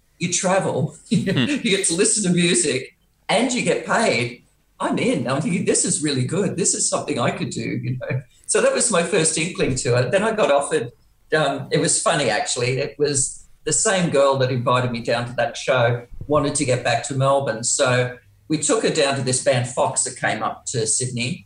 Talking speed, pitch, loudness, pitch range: 215 wpm, 140 Hz, -20 LUFS, 125-160 Hz